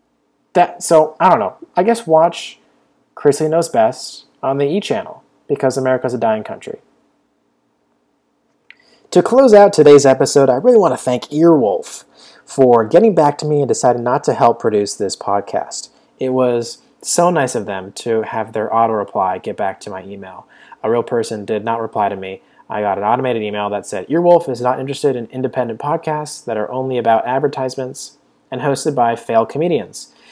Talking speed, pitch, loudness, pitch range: 180 wpm, 130 Hz, -15 LUFS, 115-155 Hz